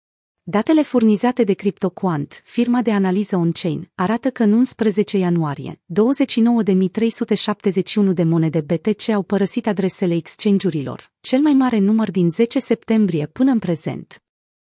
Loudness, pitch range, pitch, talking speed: -18 LUFS, 180-230 Hz, 205 Hz, 125 wpm